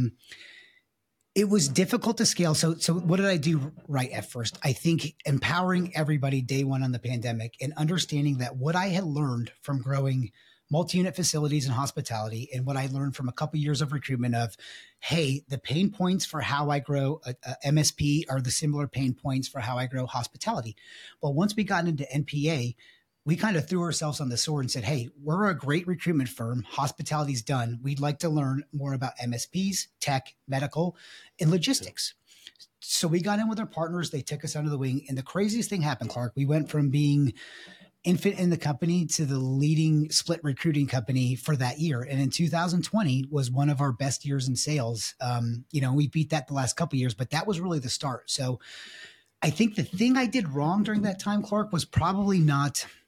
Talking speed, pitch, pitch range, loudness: 205 wpm, 145 Hz, 130-170 Hz, -28 LUFS